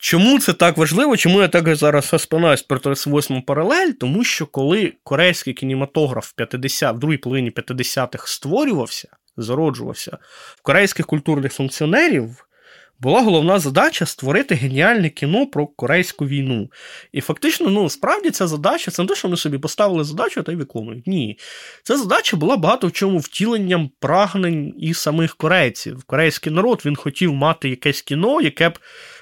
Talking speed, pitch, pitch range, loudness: 155 wpm, 160 Hz, 140-185 Hz, -18 LUFS